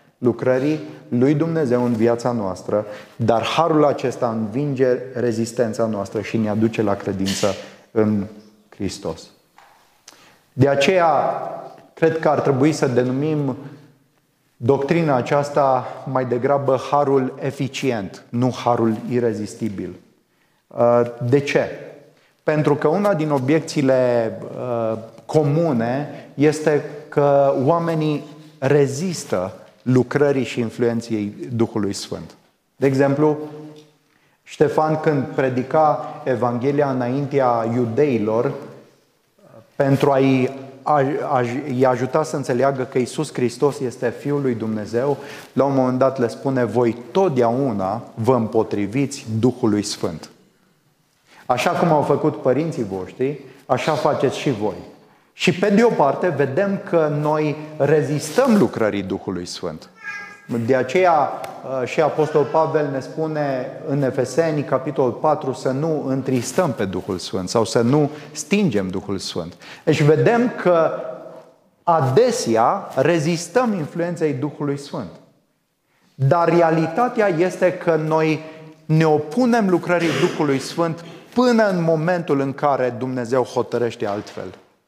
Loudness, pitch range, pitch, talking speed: -20 LUFS, 120-155 Hz, 140 Hz, 110 wpm